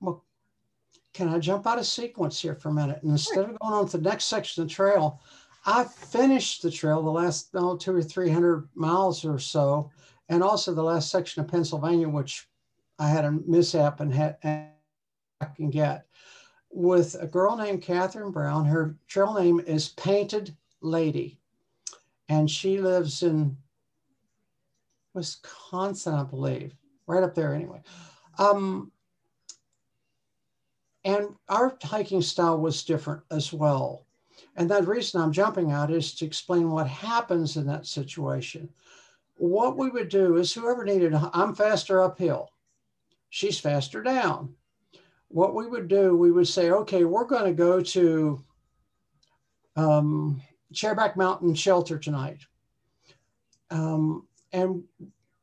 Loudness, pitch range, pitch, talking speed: -26 LUFS, 150-190 Hz, 170 Hz, 145 wpm